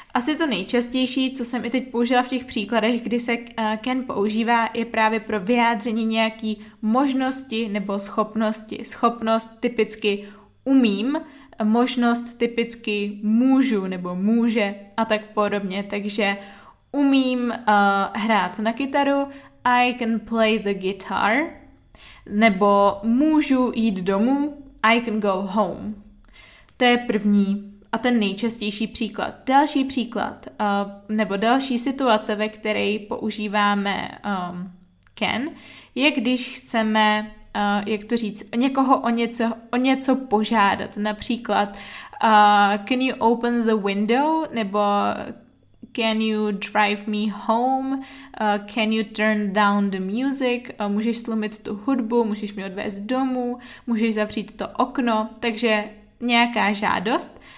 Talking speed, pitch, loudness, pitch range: 125 wpm, 225 Hz, -22 LUFS, 210-245 Hz